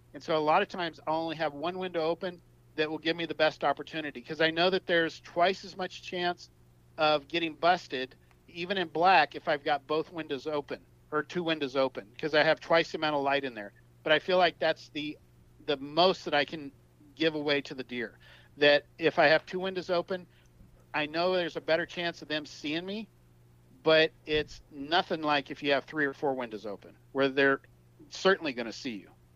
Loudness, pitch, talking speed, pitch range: -29 LUFS, 155 Hz, 215 wpm, 140-170 Hz